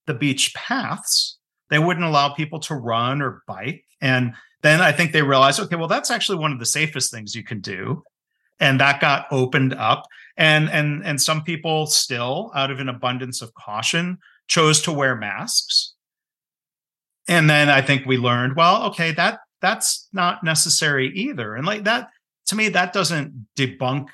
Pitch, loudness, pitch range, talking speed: 150 Hz, -19 LUFS, 130-165 Hz, 175 wpm